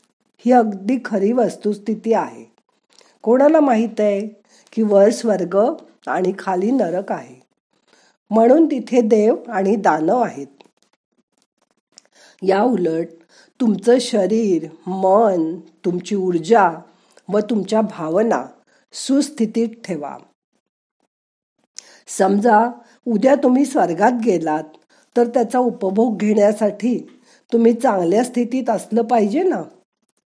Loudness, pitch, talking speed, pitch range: -18 LUFS, 220 Hz, 95 wpm, 195-240 Hz